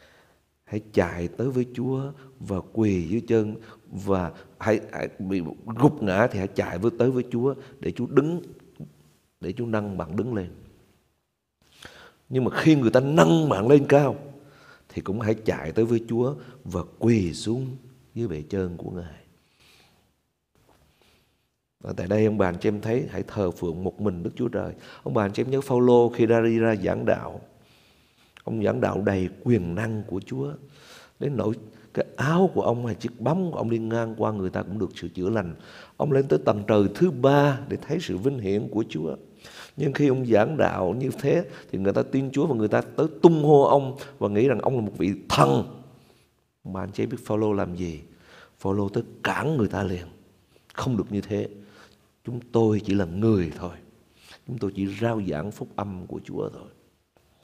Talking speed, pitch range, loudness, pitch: 195 wpm, 95-125 Hz, -25 LUFS, 110 Hz